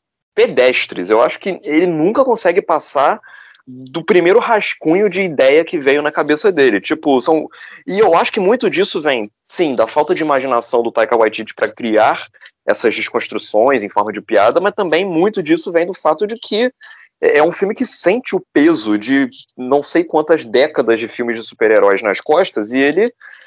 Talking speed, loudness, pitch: 185 wpm, -14 LUFS, 165 Hz